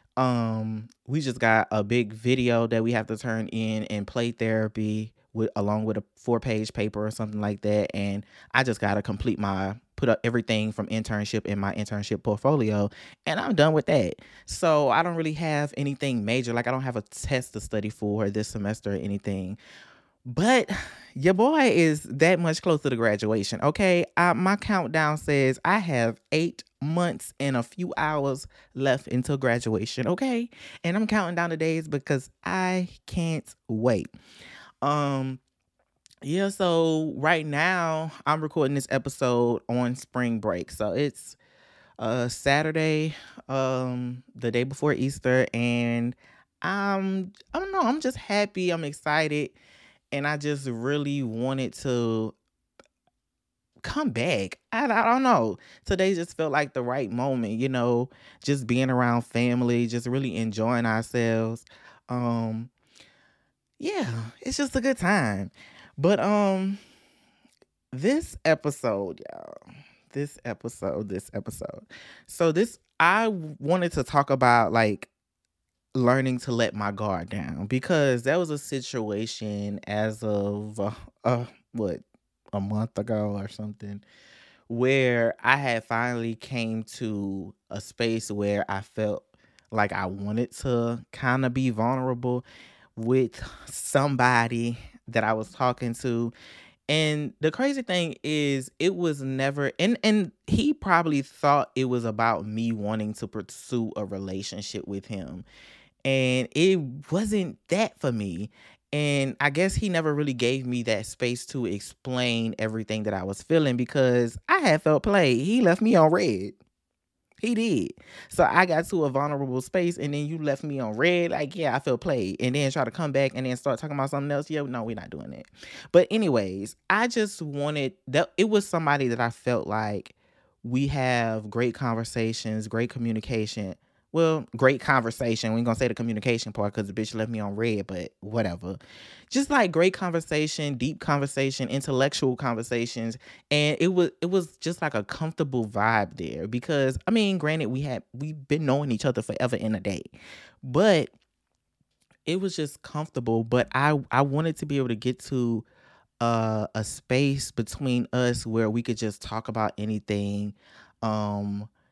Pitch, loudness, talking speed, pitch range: 125 Hz, -26 LUFS, 160 wpm, 110-150 Hz